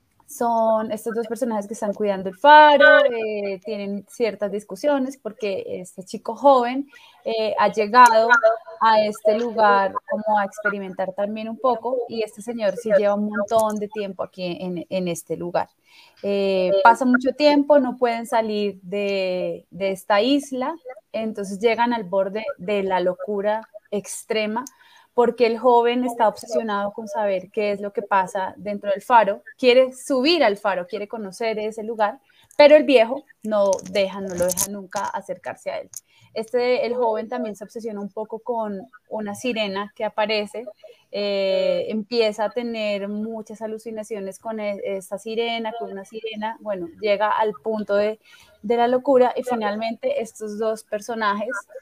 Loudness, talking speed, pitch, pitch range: -21 LUFS, 155 wpm, 220 Hz, 205-240 Hz